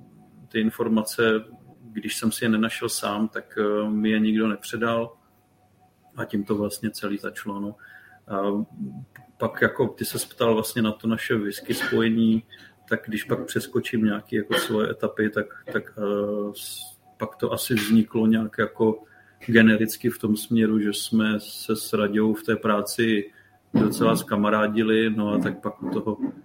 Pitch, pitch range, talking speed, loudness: 110 Hz, 105-115 Hz, 155 wpm, -24 LUFS